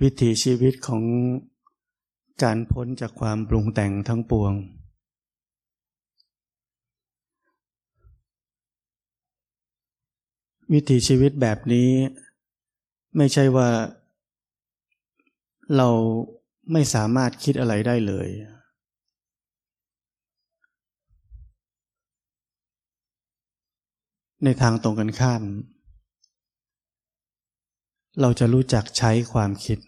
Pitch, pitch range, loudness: 120 Hz, 110-135 Hz, -22 LUFS